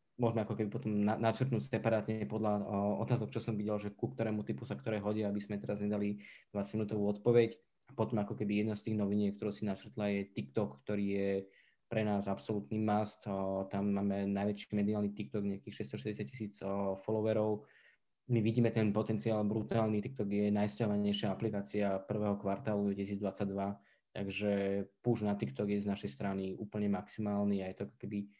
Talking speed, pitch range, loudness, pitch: 175 wpm, 100-110 Hz, -36 LUFS, 105 Hz